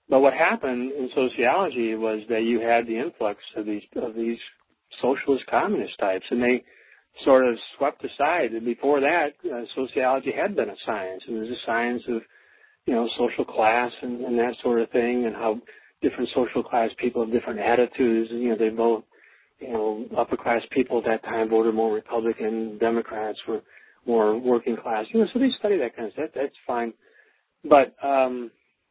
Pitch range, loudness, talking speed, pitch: 115-125 Hz, -24 LUFS, 195 wpm, 120 Hz